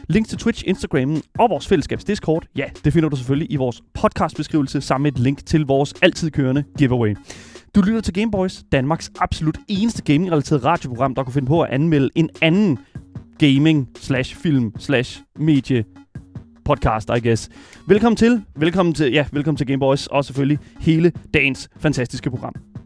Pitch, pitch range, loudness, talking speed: 145 Hz, 135-165 Hz, -19 LUFS, 155 wpm